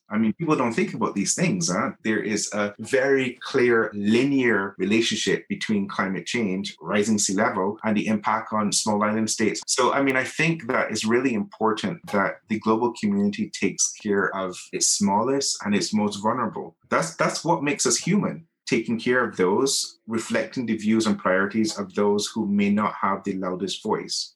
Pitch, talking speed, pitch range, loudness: 110 Hz, 185 wpm, 105-140 Hz, -23 LUFS